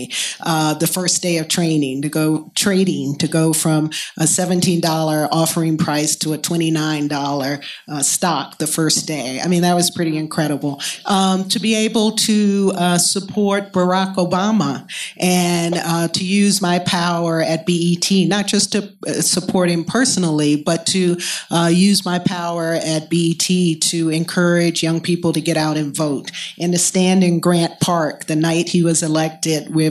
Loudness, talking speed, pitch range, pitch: -17 LUFS, 165 wpm, 160-180 Hz, 170 Hz